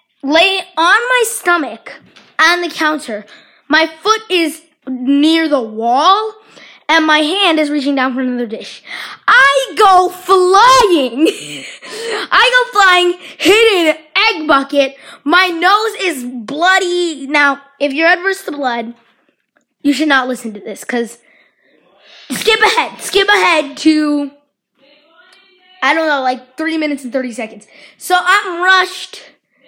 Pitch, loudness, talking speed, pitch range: 320 Hz, -12 LUFS, 135 wpm, 275-370 Hz